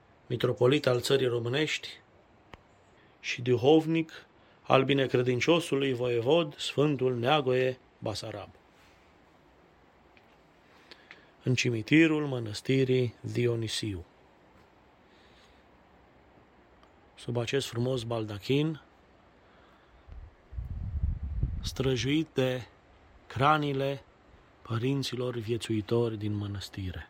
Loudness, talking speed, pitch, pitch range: -29 LUFS, 60 wpm, 120 Hz, 105-135 Hz